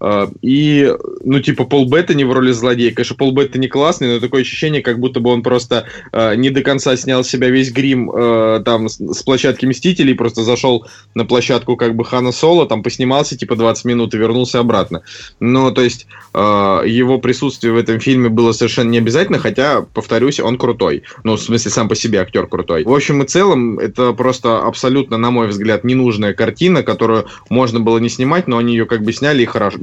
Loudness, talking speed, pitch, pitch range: -14 LUFS, 205 wpm, 120 Hz, 115-130 Hz